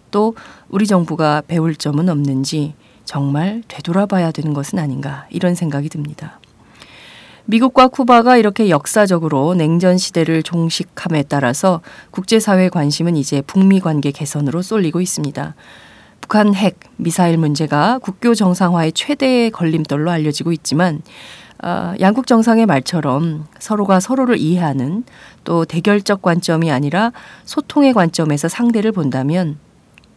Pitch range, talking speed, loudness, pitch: 150-205 Hz, 310 characters per minute, -15 LUFS, 170 Hz